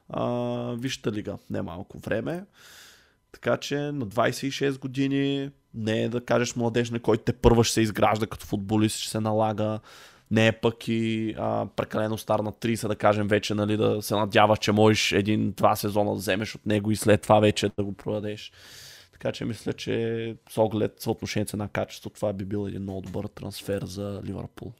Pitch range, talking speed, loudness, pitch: 105-115 Hz, 190 wpm, -26 LUFS, 110 Hz